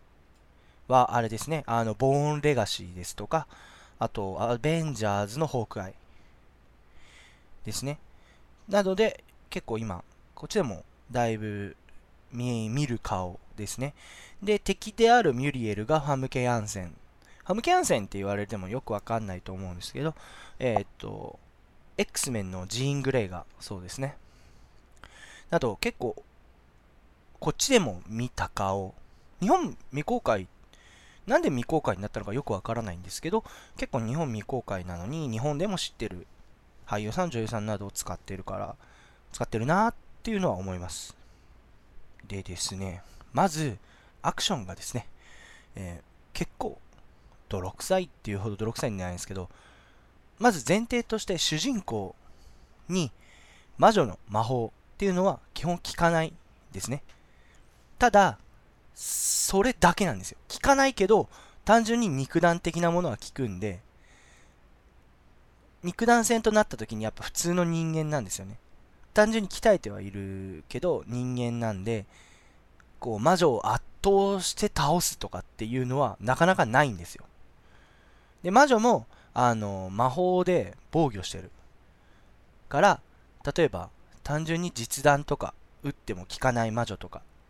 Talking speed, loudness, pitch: 295 characters per minute, -28 LUFS, 115 Hz